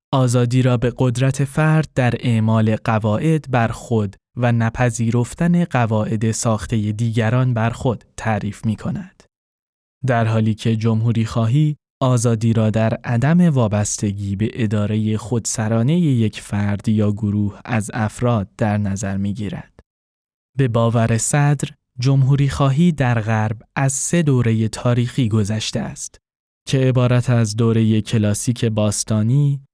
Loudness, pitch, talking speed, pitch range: -18 LUFS, 115 Hz, 125 wpm, 110-130 Hz